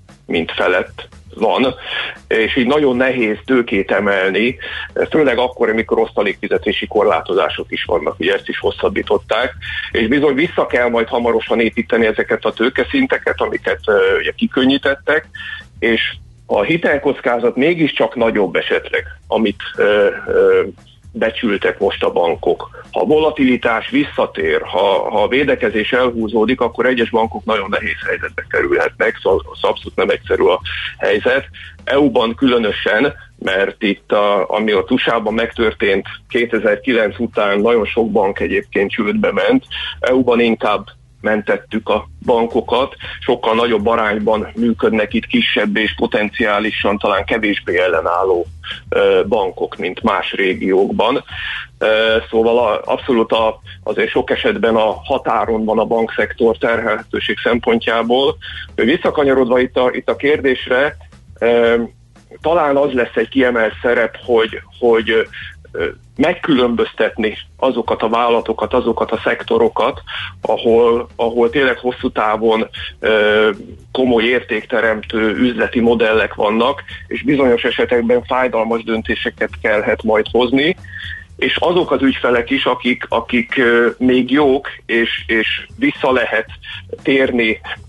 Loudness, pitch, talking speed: -16 LUFS, 130 Hz, 120 wpm